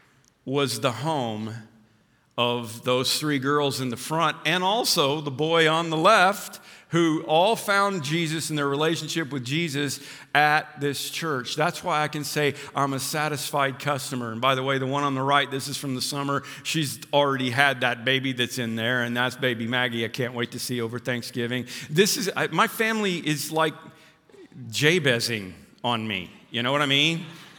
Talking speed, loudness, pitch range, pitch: 185 wpm, -24 LUFS, 125-155 Hz, 140 Hz